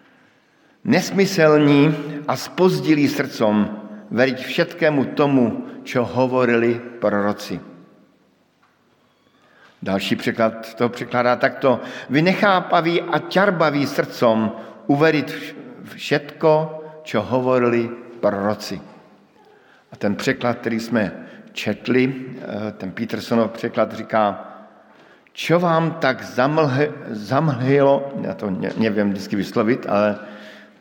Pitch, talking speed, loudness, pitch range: 130 Hz, 90 wpm, -20 LUFS, 110-155 Hz